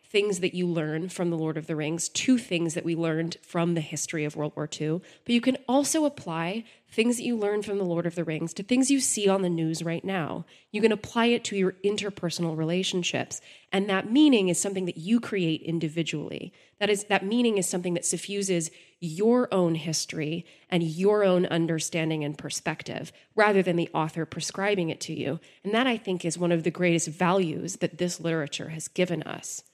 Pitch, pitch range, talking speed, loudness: 175 Hz, 165-200 Hz, 210 wpm, -27 LUFS